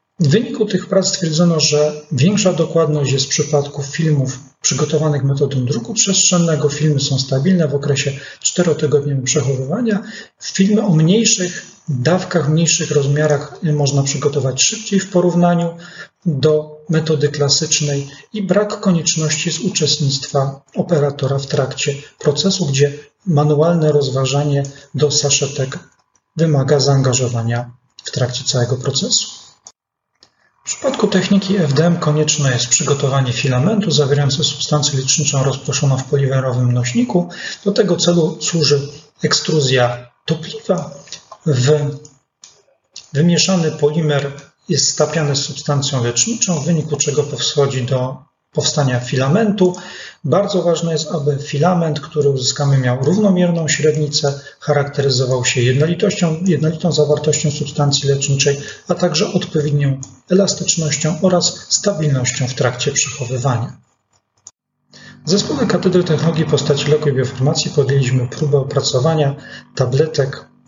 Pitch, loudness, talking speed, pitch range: 150 Hz, -16 LUFS, 110 wpm, 140-170 Hz